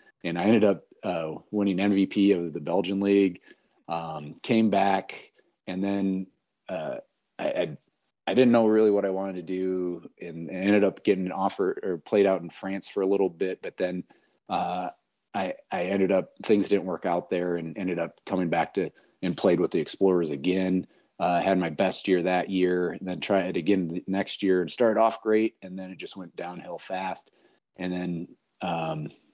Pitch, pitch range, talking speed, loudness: 95 Hz, 90-100 Hz, 200 wpm, -27 LUFS